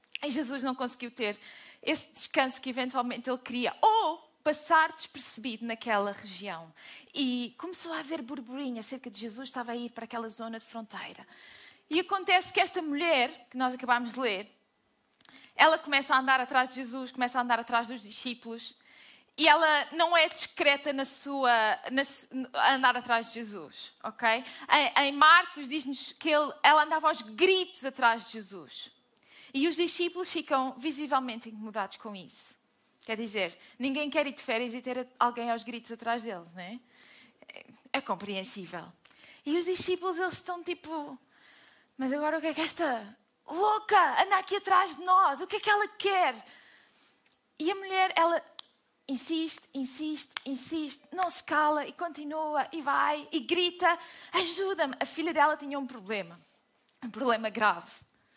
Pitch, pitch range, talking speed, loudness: 275 Hz, 240-320 Hz, 165 wpm, -29 LUFS